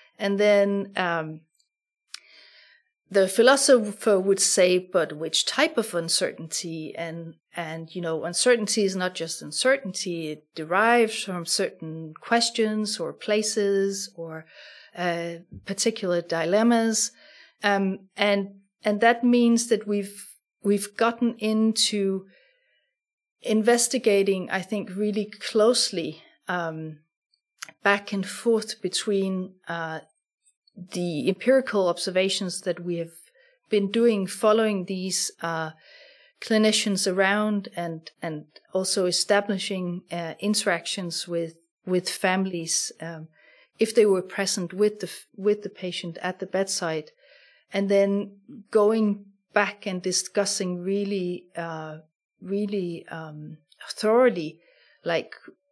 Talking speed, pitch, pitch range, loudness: 110 wpm, 195 Hz, 175-215 Hz, -24 LUFS